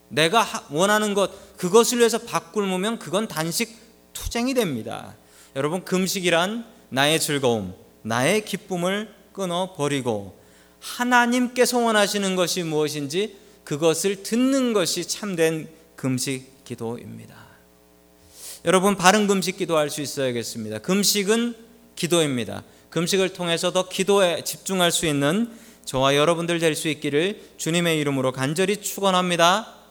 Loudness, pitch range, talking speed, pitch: -22 LUFS, 145-205 Hz, 295 characters per minute, 180 Hz